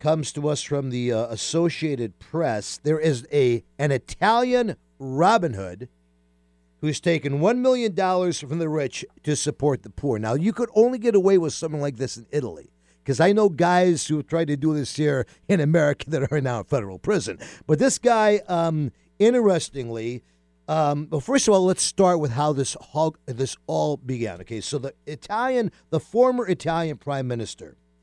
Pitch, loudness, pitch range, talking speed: 150 Hz, -23 LUFS, 125-175 Hz, 180 wpm